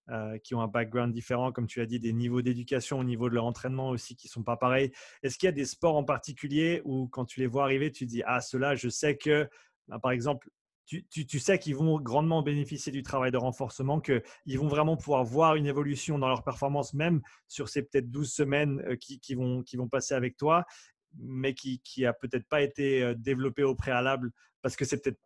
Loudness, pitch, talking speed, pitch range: -30 LUFS, 135 Hz, 235 wpm, 125-145 Hz